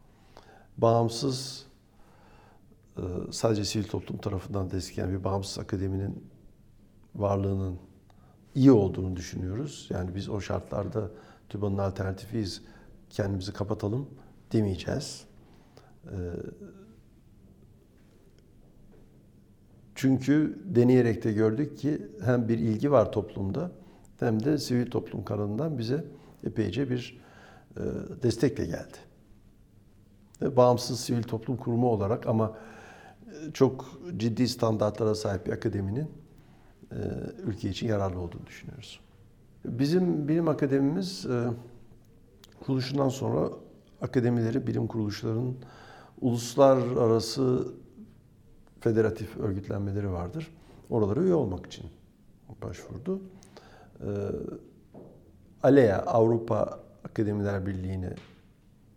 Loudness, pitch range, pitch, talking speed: -29 LUFS, 100-125 Hz, 110 Hz, 80 wpm